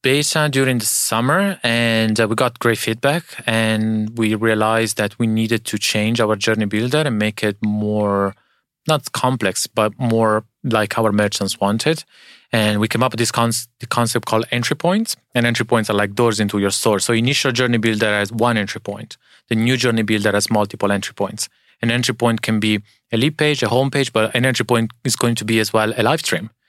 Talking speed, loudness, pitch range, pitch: 215 wpm, -18 LUFS, 110-120 Hz, 115 Hz